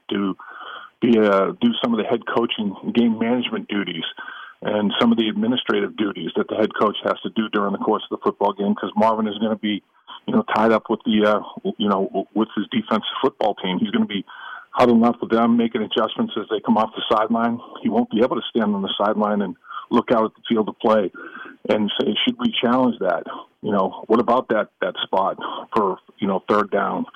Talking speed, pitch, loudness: 230 wpm, 115 Hz, -21 LUFS